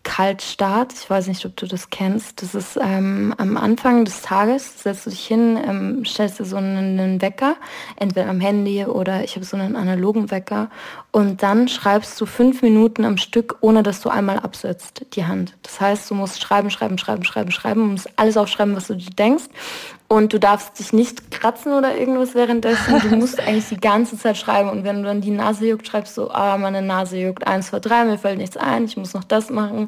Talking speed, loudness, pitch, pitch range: 220 wpm, -19 LUFS, 210 Hz, 195-230 Hz